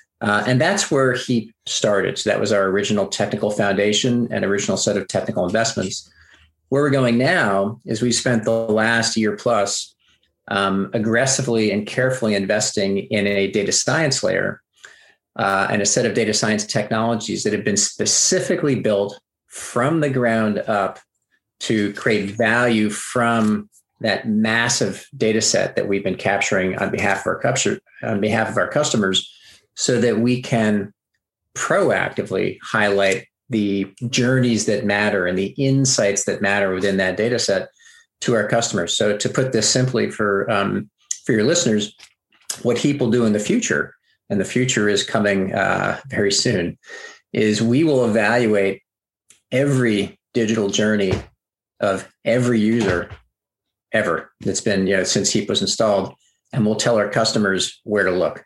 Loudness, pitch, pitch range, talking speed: -19 LUFS, 110 Hz, 100-120 Hz, 155 wpm